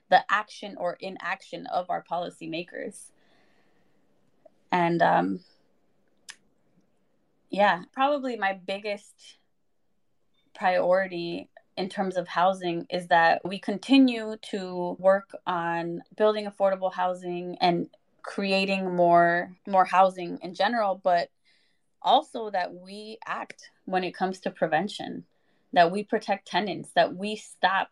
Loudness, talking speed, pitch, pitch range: -26 LUFS, 110 wpm, 190 Hz, 175-210 Hz